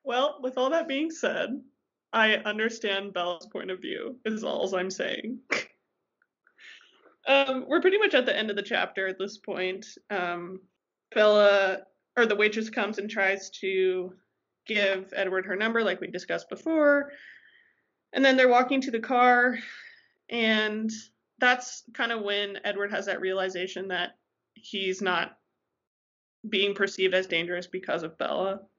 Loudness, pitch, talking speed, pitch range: -27 LUFS, 215 Hz, 150 wpm, 190-255 Hz